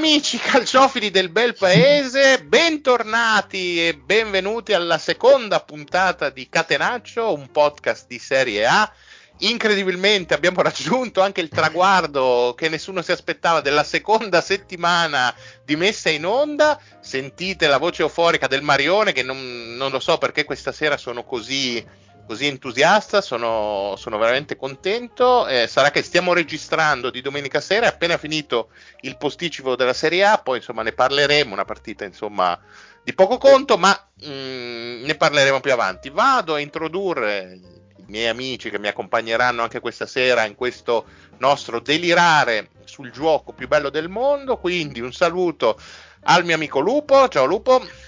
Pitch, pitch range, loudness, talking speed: 160 Hz, 130-200 Hz, -19 LUFS, 150 wpm